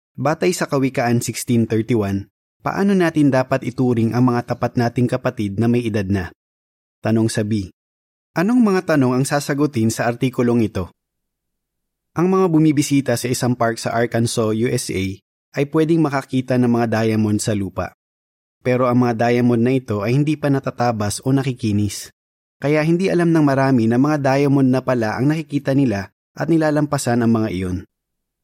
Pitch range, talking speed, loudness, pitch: 105-140 Hz, 160 wpm, -18 LUFS, 120 Hz